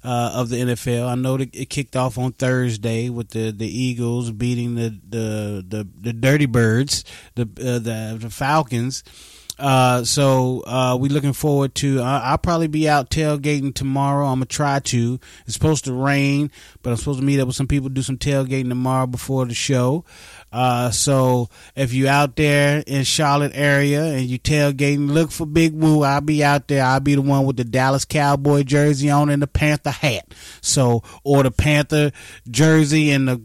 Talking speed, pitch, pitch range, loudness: 190 wpm, 135 Hz, 120-145 Hz, -19 LUFS